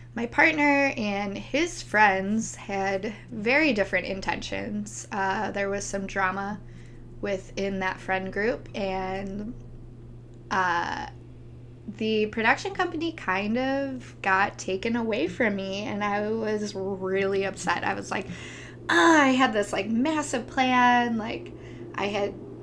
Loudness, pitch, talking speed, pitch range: -26 LUFS, 200 Hz, 125 wpm, 190-235 Hz